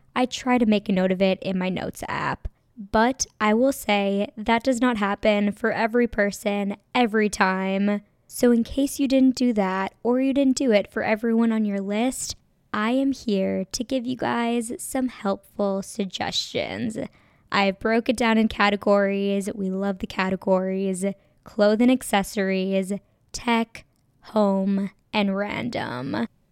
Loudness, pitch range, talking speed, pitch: -23 LUFS, 195-235 Hz, 155 wpm, 210 Hz